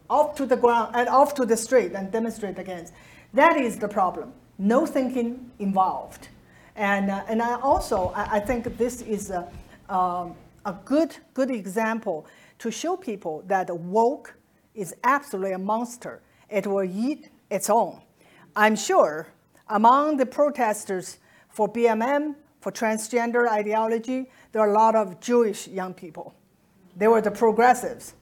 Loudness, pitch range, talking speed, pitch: -24 LUFS, 195-250 Hz, 150 wpm, 225 Hz